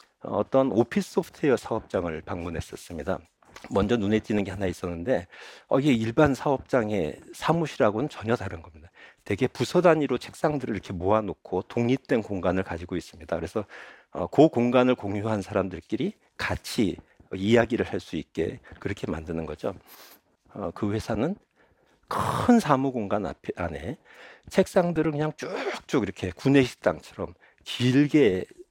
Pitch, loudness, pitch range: 120 Hz, -26 LUFS, 100-145 Hz